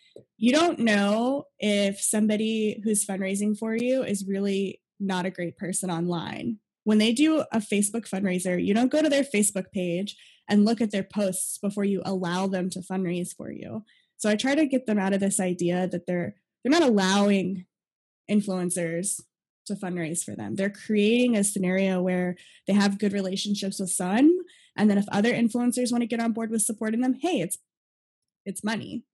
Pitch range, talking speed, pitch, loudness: 190-230 Hz, 185 wpm, 205 Hz, -25 LUFS